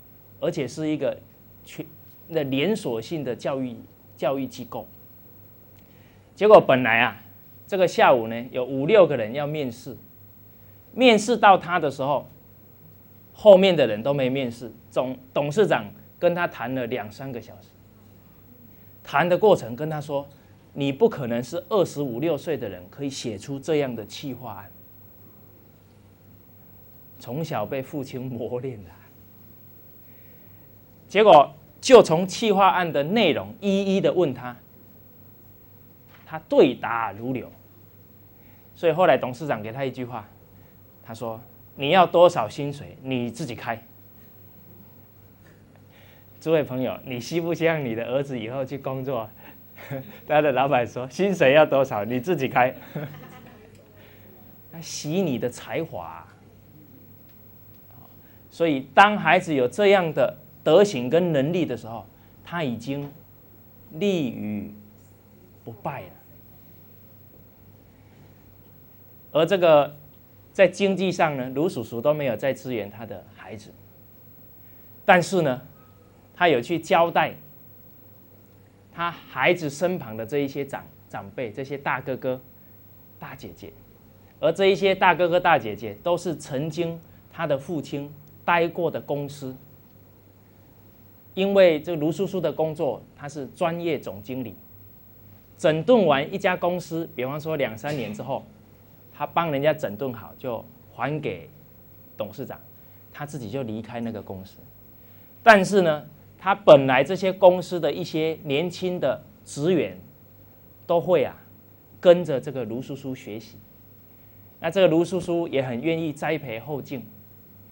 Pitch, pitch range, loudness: 120 Hz, 105-150 Hz, -23 LUFS